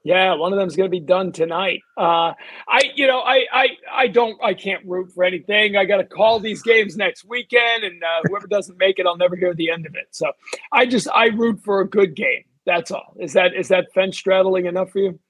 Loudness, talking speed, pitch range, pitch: -18 LUFS, 245 wpm, 180-225 Hz, 195 Hz